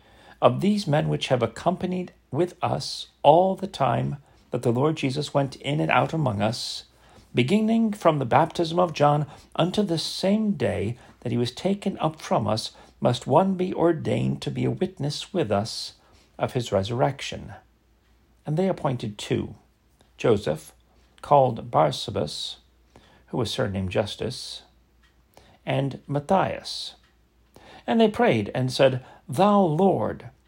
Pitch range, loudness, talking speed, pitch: 115-180 Hz, -24 LUFS, 140 wpm, 145 Hz